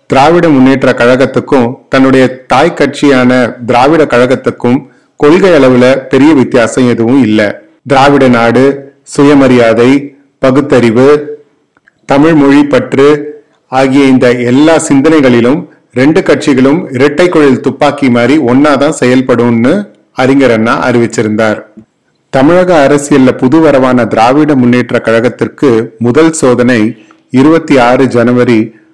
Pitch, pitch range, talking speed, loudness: 130 Hz, 120-145 Hz, 95 wpm, -6 LUFS